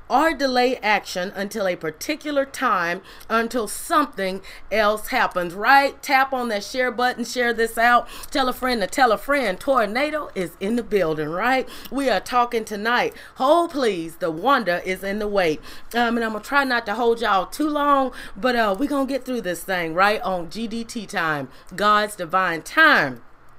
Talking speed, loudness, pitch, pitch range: 180 wpm, -21 LUFS, 230 Hz, 195-265 Hz